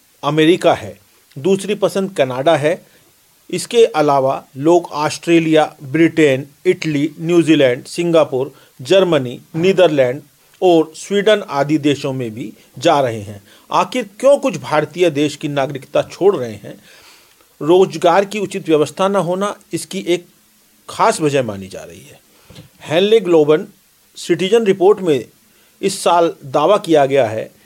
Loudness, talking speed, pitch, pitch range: -15 LUFS, 130 wpm, 165 Hz, 145-185 Hz